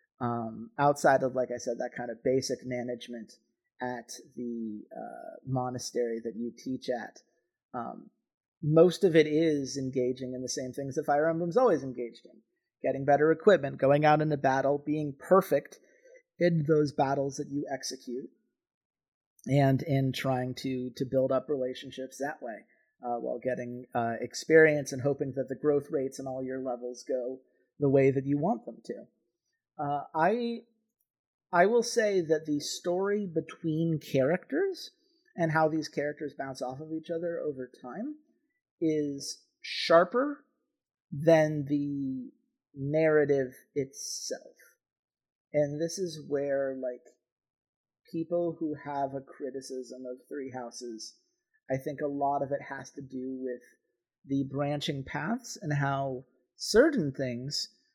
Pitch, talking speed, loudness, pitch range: 140 Hz, 145 wpm, -30 LUFS, 130-165 Hz